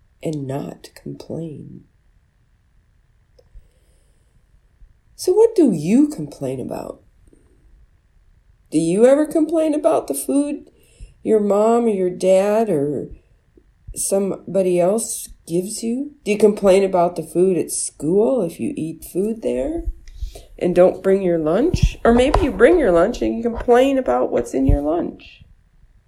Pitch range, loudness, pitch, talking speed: 165-245 Hz, -18 LUFS, 195 Hz, 135 wpm